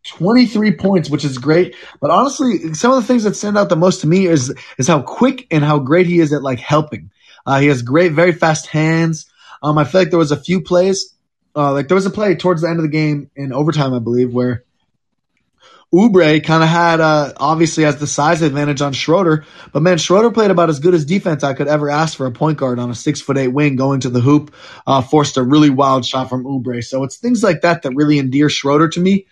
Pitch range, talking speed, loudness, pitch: 140-180 Hz, 250 wpm, -14 LUFS, 155 Hz